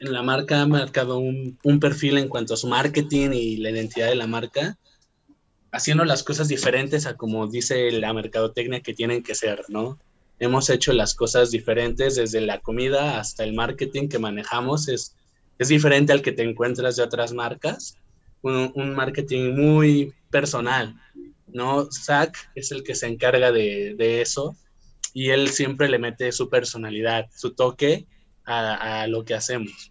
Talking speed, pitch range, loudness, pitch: 170 wpm, 115-140 Hz, -22 LUFS, 125 Hz